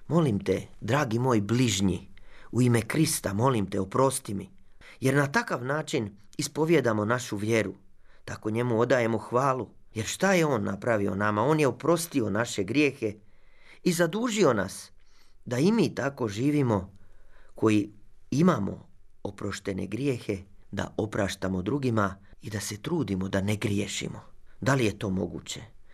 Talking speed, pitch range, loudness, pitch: 140 wpm, 100-130 Hz, -27 LUFS, 110 Hz